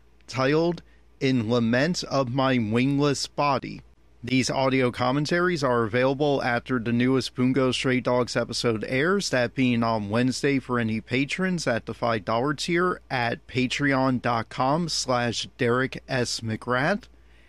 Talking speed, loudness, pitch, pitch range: 125 wpm, -24 LUFS, 125 Hz, 120-135 Hz